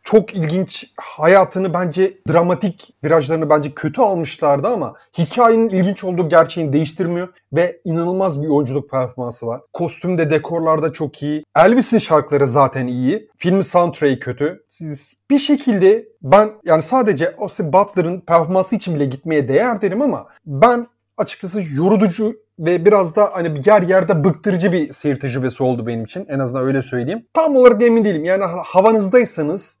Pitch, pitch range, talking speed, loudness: 175 Hz, 150-205 Hz, 145 wpm, -16 LUFS